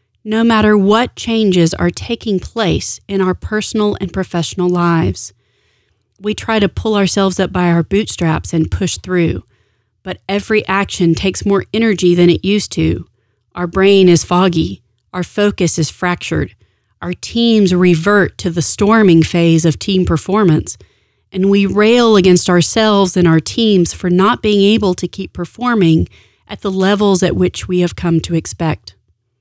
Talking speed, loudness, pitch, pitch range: 160 wpm, -13 LUFS, 180 Hz, 165-205 Hz